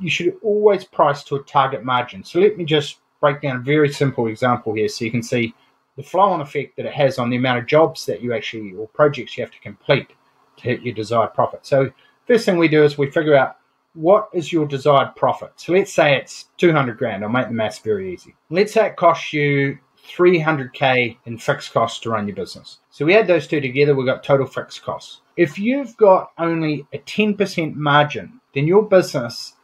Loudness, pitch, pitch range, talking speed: -18 LUFS, 145 Hz, 125-175 Hz, 220 wpm